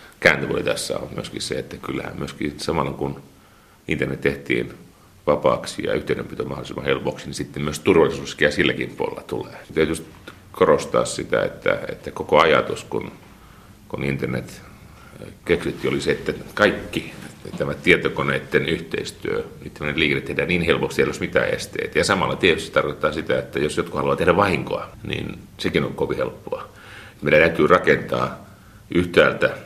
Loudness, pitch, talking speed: -22 LUFS, 90 Hz, 150 wpm